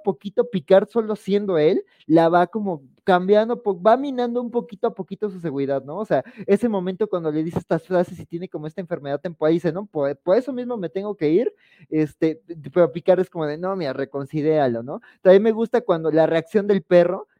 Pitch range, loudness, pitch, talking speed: 165-215 Hz, -21 LUFS, 185 Hz, 215 wpm